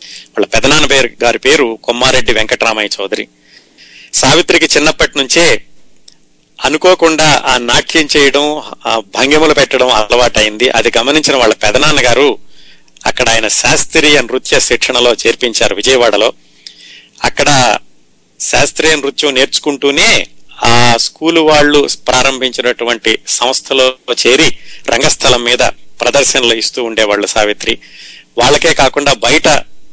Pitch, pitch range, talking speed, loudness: 130 Hz, 115-145 Hz, 100 wpm, -9 LUFS